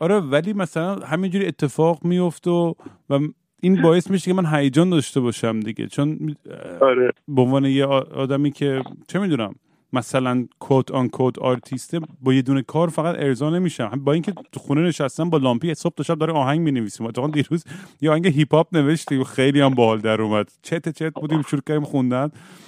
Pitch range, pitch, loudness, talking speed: 135-165 Hz, 150 Hz, -21 LUFS, 185 wpm